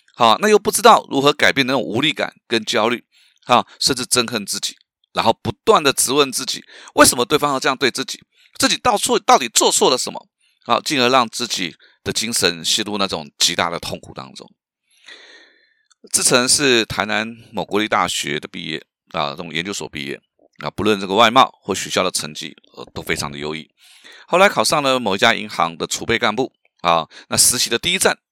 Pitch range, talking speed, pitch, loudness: 100-145 Hz, 300 characters per minute, 115 Hz, -17 LUFS